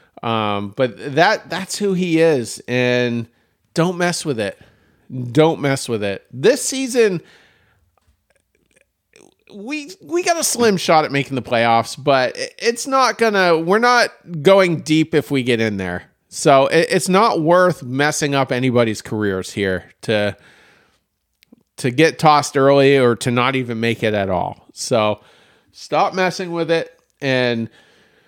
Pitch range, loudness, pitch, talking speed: 120-180 Hz, -17 LUFS, 140 Hz, 140 wpm